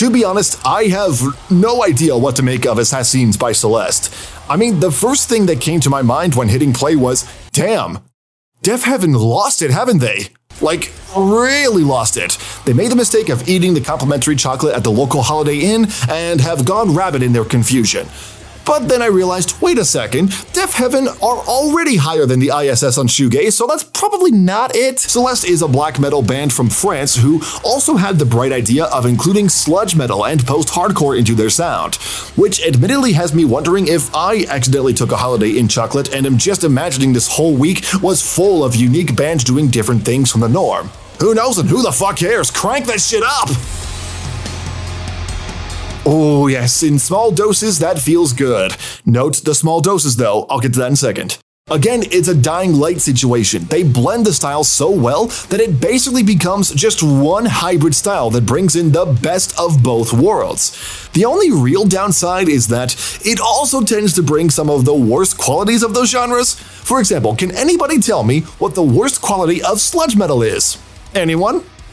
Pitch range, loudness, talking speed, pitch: 125-195 Hz, -13 LUFS, 190 wpm, 150 Hz